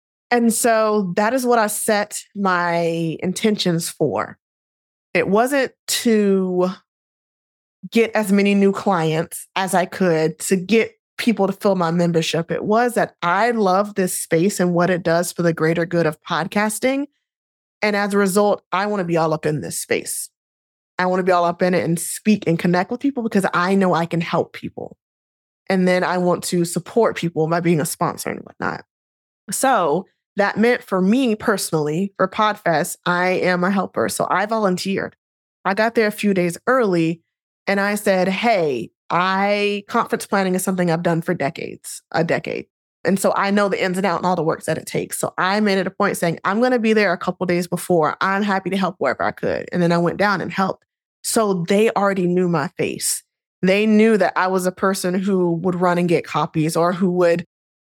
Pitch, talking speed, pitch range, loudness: 185 Hz, 205 wpm, 170-205 Hz, -19 LUFS